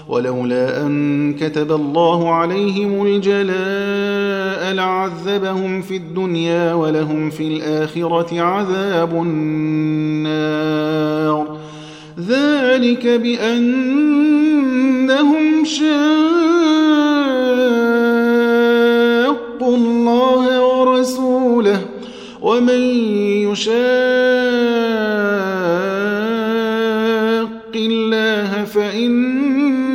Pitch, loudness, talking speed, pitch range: 220 Hz, -16 LUFS, 45 wpm, 170-250 Hz